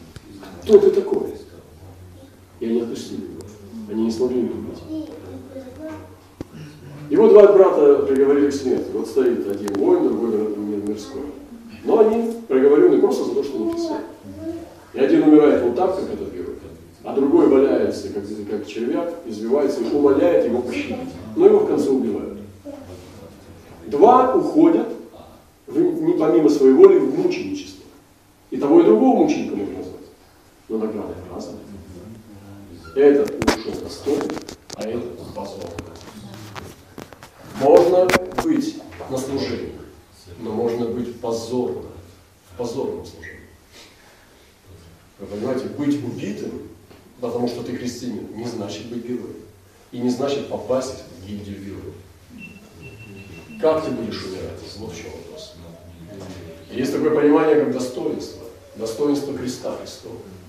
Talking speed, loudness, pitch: 125 wpm, -19 LUFS, 125 Hz